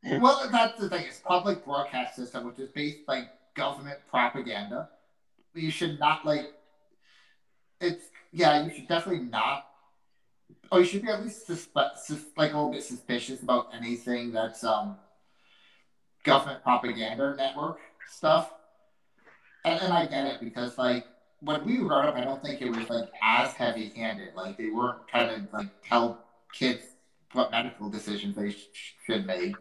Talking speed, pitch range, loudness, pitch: 165 wpm, 120-155 Hz, -29 LUFS, 135 Hz